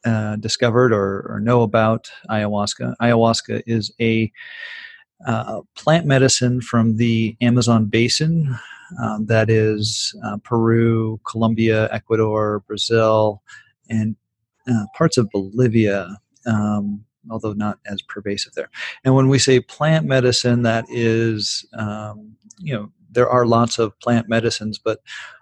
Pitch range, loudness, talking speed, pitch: 110-125 Hz, -19 LUFS, 125 wpm, 115 Hz